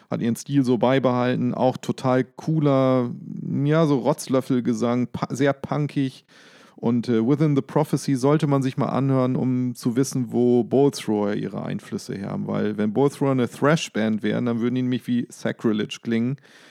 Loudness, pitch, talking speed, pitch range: -23 LUFS, 130 Hz, 165 wpm, 120-145 Hz